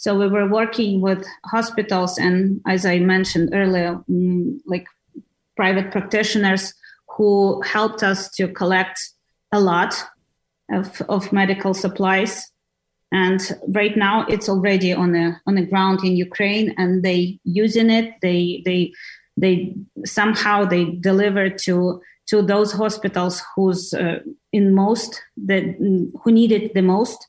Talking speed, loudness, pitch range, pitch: 130 wpm, -19 LUFS, 185-210 Hz, 195 Hz